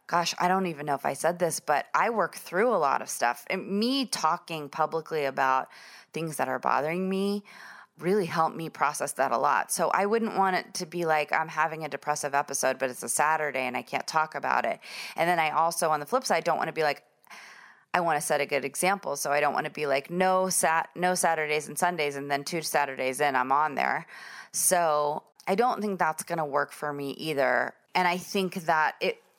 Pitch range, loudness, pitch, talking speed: 145-180 Hz, -27 LUFS, 160 Hz, 230 wpm